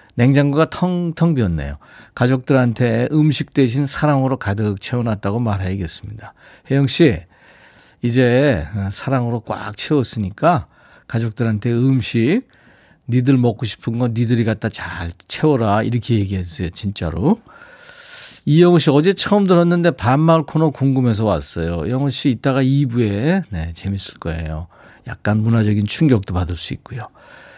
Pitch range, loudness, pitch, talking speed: 100-145 Hz, -18 LUFS, 120 Hz, 305 characters per minute